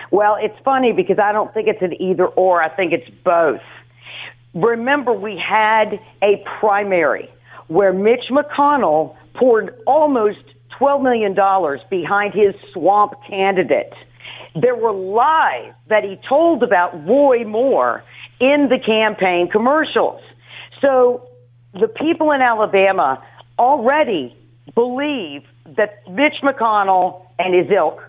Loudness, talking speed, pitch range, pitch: -16 LUFS, 120 wpm, 185-245 Hz, 210 Hz